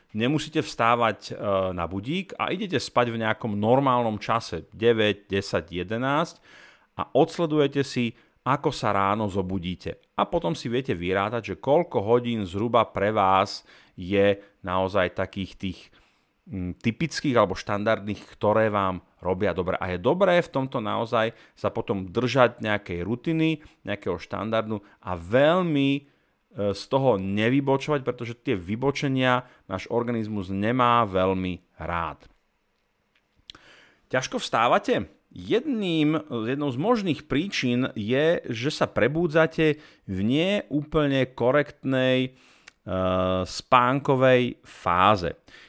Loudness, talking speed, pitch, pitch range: -25 LUFS, 115 wpm, 115 Hz, 100-135 Hz